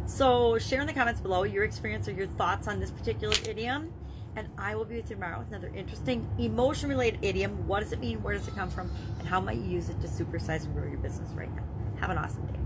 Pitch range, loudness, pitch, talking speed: 95-115 Hz, -31 LUFS, 110 Hz, 260 wpm